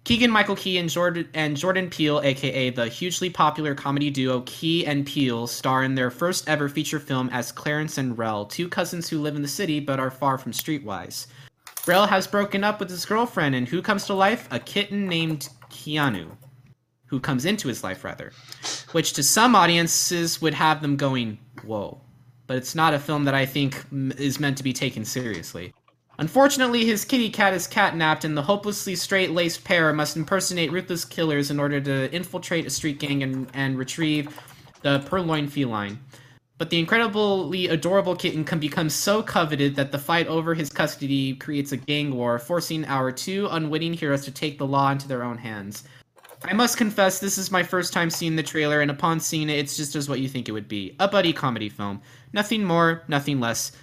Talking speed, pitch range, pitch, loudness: 195 wpm, 135-175 Hz, 150 Hz, -23 LUFS